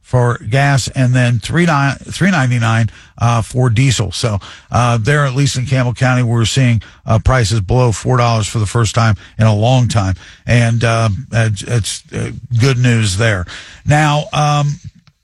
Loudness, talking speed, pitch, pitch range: -14 LUFS, 150 wpm, 120 Hz, 110-130 Hz